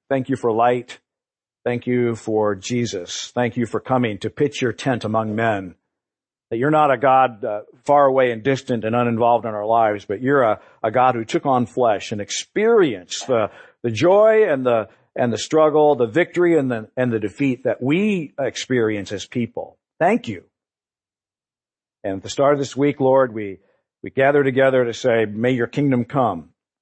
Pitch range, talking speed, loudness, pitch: 115-135 Hz, 190 wpm, -19 LUFS, 125 Hz